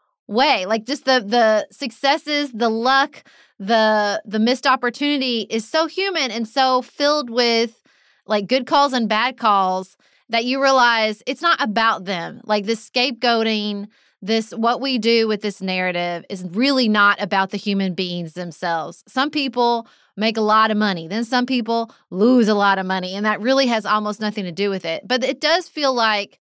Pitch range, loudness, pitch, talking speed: 210-260 Hz, -19 LUFS, 225 Hz, 180 wpm